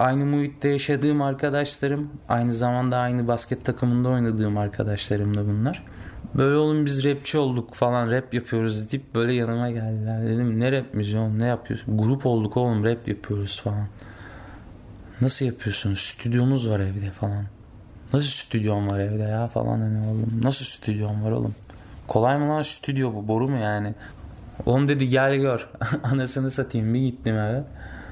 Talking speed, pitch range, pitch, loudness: 155 wpm, 105-130 Hz, 120 Hz, -24 LUFS